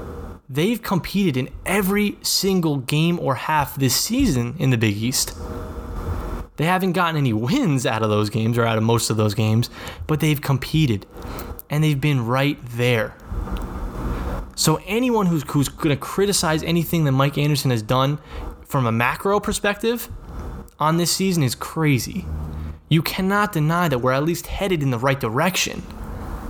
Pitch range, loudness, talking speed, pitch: 110-170 Hz, -21 LUFS, 165 wpm, 140 Hz